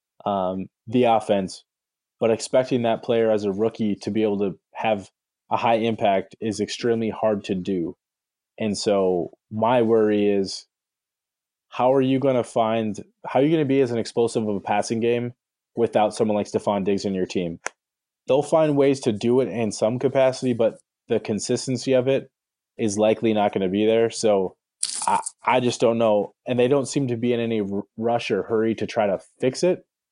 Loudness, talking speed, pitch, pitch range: -23 LUFS, 195 wpm, 115 Hz, 105-125 Hz